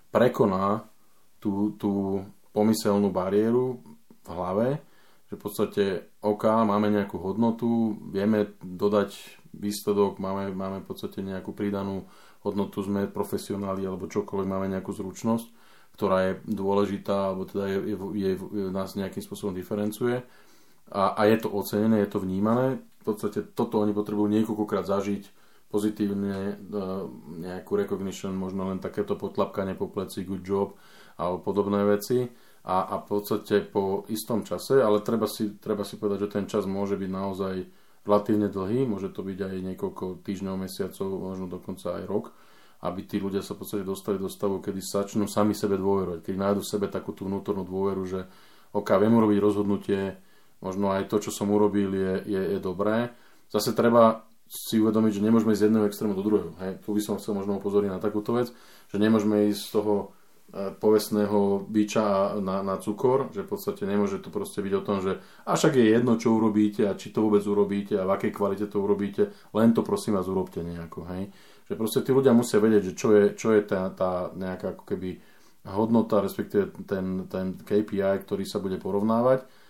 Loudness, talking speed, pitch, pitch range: -27 LUFS, 175 wpm, 100 Hz, 95-105 Hz